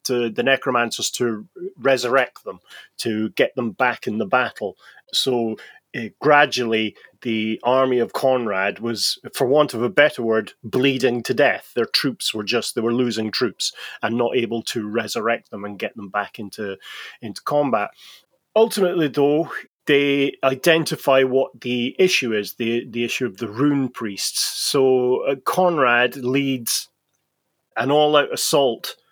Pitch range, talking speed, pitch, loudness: 115-140 Hz, 150 wpm, 125 Hz, -20 LUFS